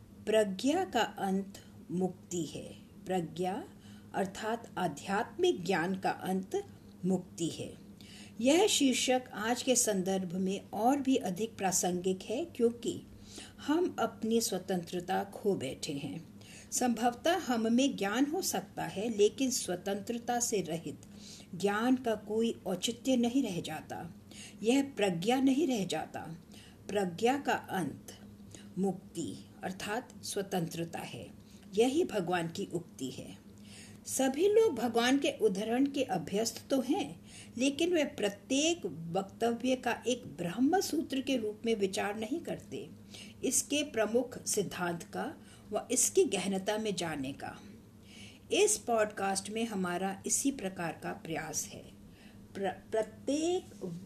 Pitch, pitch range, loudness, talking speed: 210 Hz, 185-255 Hz, -33 LUFS, 120 wpm